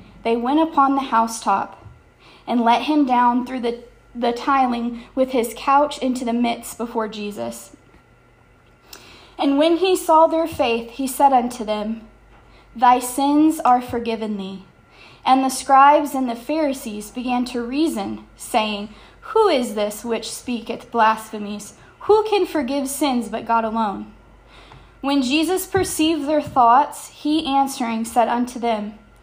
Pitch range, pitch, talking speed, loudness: 225-280 Hz, 245 Hz, 140 wpm, -19 LUFS